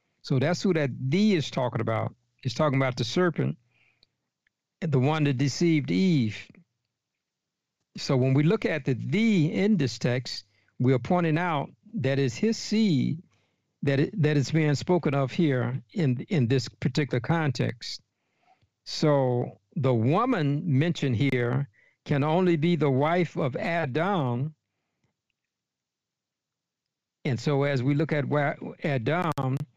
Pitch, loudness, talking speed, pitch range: 145 Hz, -26 LUFS, 140 wpm, 130-170 Hz